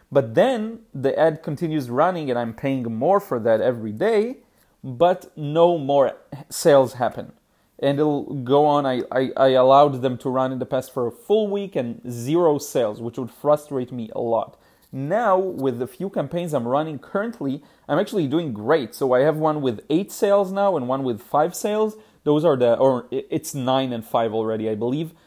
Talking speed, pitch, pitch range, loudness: 195 wpm, 140 Hz, 130-170 Hz, -21 LUFS